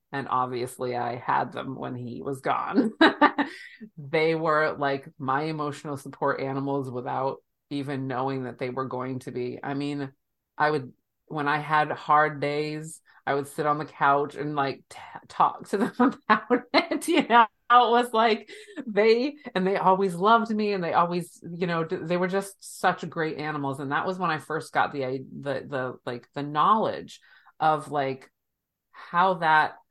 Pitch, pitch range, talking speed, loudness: 150 Hz, 135-195 Hz, 175 wpm, -26 LUFS